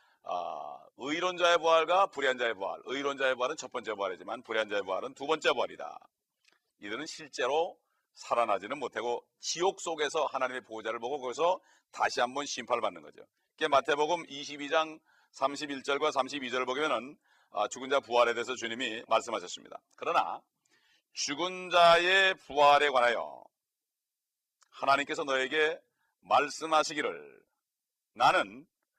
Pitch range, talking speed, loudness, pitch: 130-170 Hz, 315 characters per minute, -30 LUFS, 145 Hz